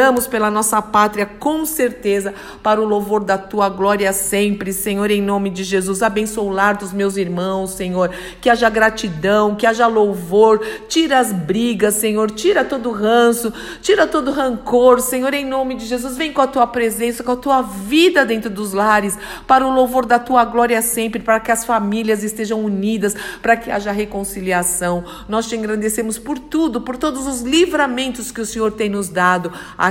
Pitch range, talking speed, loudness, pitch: 205-250 Hz, 180 wpm, -17 LUFS, 220 Hz